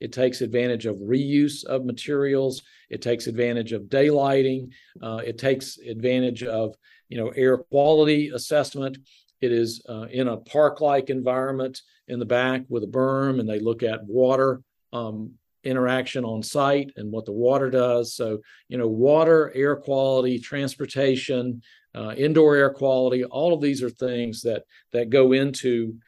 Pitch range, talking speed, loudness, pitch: 120-135 Hz, 160 wpm, -23 LUFS, 130 Hz